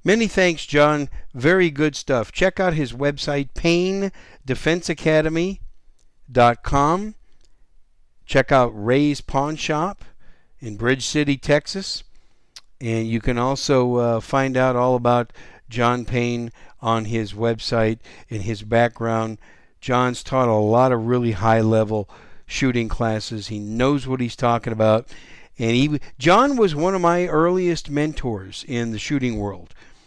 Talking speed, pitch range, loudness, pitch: 130 wpm, 115-150 Hz, -20 LUFS, 125 Hz